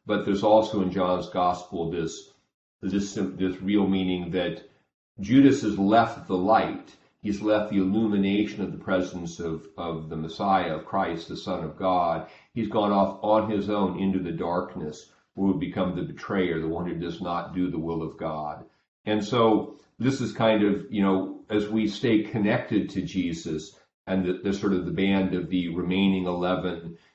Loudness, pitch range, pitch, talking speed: -26 LUFS, 90-105 Hz, 95 Hz, 185 wpm